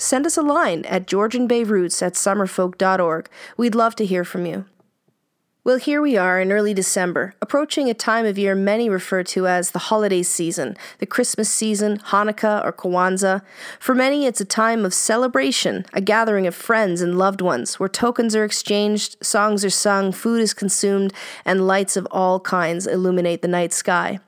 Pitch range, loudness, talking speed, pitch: 185-220 Hz, -19 LUFS, 180 wpm, 200 Hz